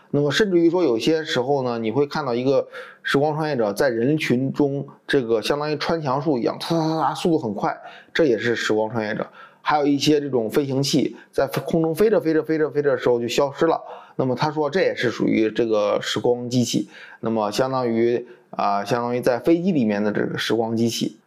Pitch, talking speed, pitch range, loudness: 140 Hz, 335 characters per minute, 120-155 Hz, -21 LUFS